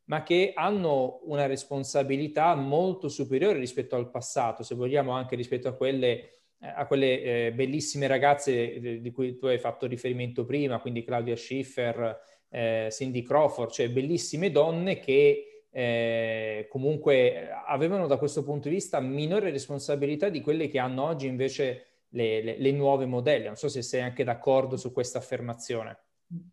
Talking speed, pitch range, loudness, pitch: 155 wpm, 120-145 Hz, -28 LUFS, 135 Hz